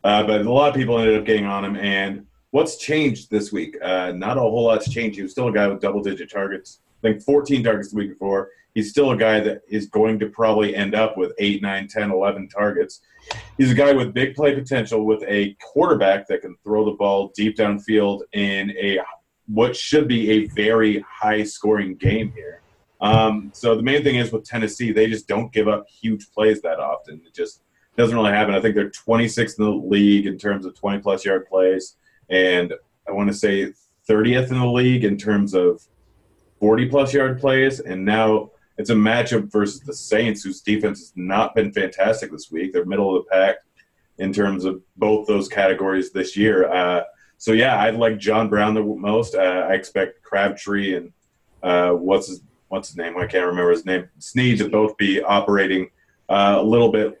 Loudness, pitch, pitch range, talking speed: -20 LUFS, 105 Hz, 100-110 Hz, 205 wpm